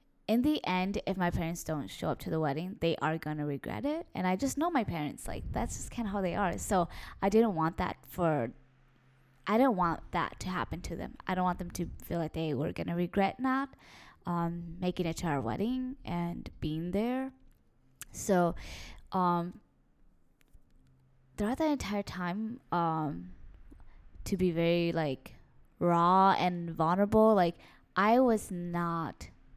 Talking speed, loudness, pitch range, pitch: 170 wpm, -32 LUFS, 155-200 Hz, 175 Hz